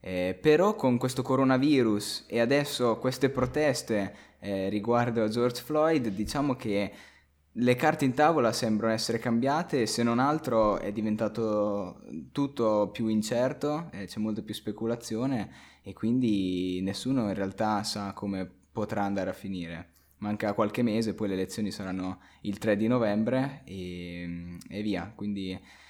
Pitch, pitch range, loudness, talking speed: 105 Hz, 95-125 Hz, -29 LUFS, 145 wpm